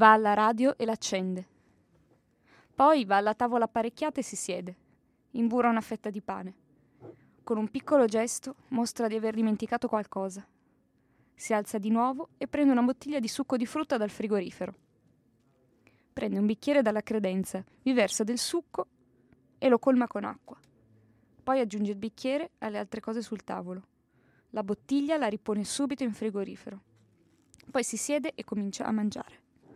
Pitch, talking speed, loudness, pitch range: 220 Hz, 155 wpm, -30 LUFS, 200-250 Hz